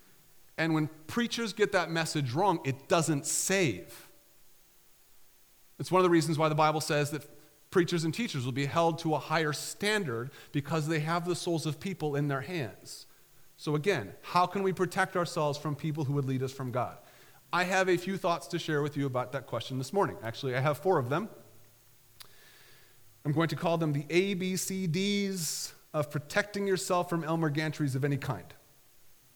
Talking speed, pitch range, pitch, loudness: 185 wpm, 140-175 Hz, 155 Hz, -31 LUFS